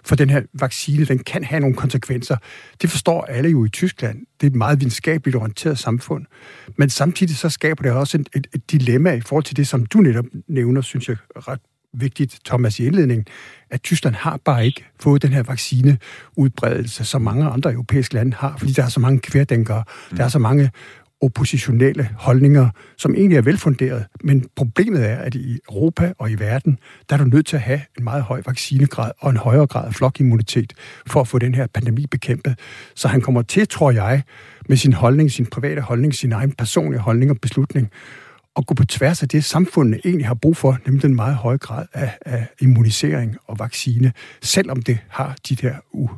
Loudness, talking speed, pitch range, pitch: -18 LUFS, 200 wpm, 125-145 Hz, 135 Hz